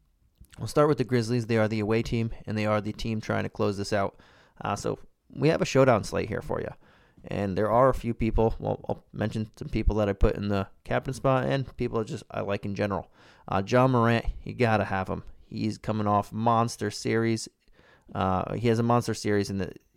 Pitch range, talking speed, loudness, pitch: 100-115 Hz, 230 wpm, -27 LUFS, 110 Hz